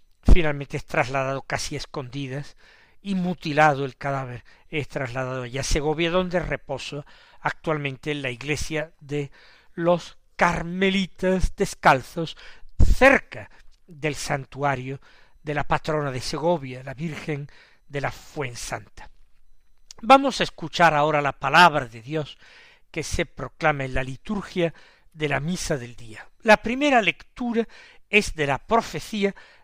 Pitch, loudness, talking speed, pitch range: 150 Hz, -24 LUFS, 130 wpm, 135-175 Hz